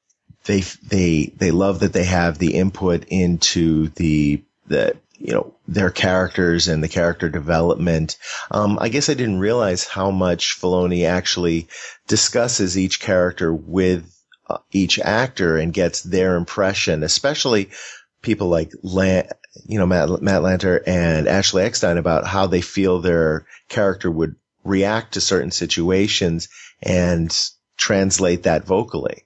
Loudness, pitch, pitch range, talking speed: -19 LUFS, 90 Hz, 85-95 Hz, 135 wpm